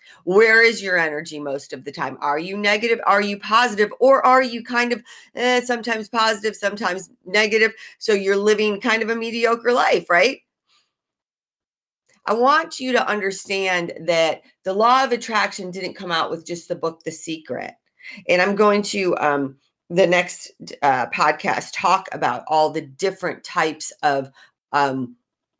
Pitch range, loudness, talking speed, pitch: 165-230 Hz, -20 LUFS, 160 wpm, 200 Hz